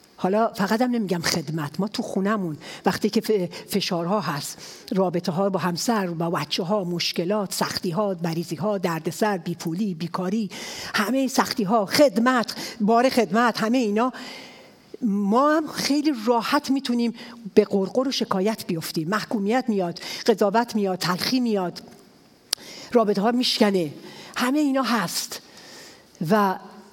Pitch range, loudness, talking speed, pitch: 185-235 Hz, -23 LUFS, 130 wpm, 210 Hz